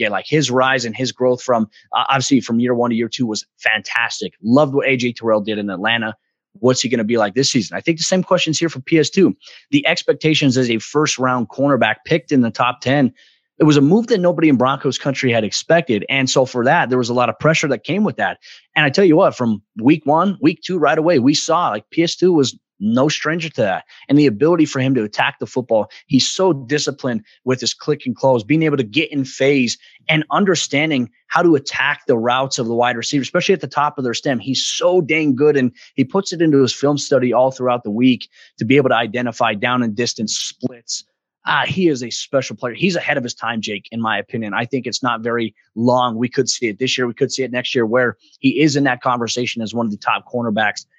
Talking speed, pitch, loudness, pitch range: 245 wpm, 130 Hz, -17 LUFS, 120-150 Hz